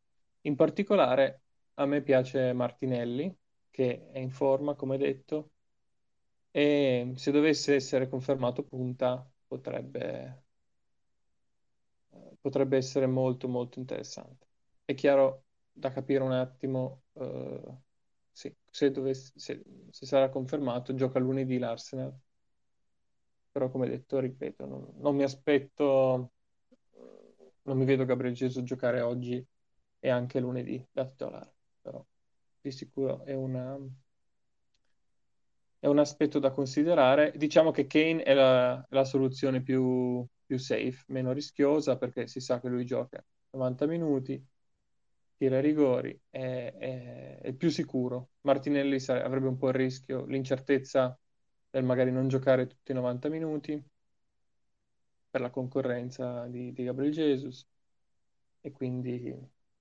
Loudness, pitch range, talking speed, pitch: -30 LUFS, 125-140 Hz, 125 wpm, 130 Hz